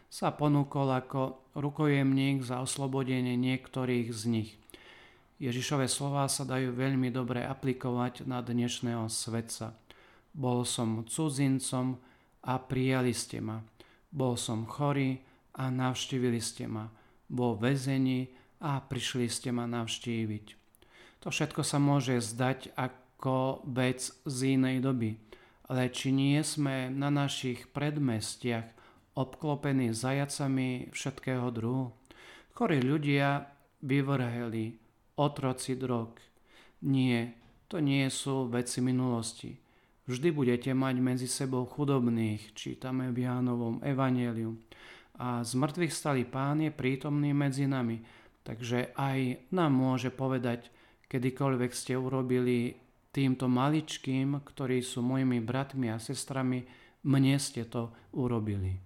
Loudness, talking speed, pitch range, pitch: -32 LUFS, 115 wpm, 120-135 Hz, 130 Hz